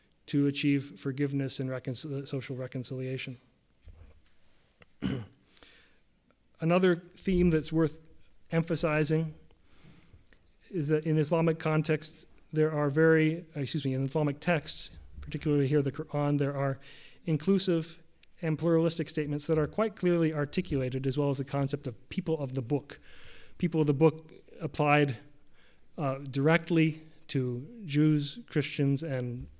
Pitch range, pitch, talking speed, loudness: 135-160 Hz, 150 Hz, 120 wpm, -30 LUFS